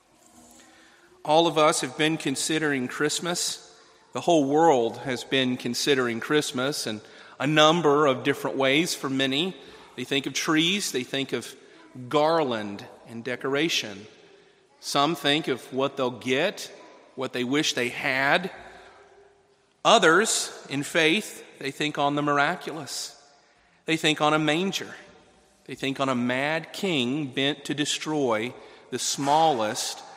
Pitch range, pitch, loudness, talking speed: 135-160 Hz, 145 Hz, -24 LUFS, 135 wpm